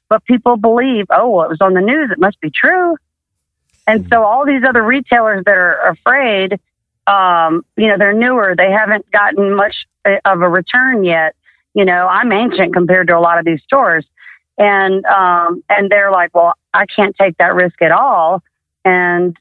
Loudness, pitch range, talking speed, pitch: -11 LUFS, 180-220 Hz, 190 wpm, 195 Hz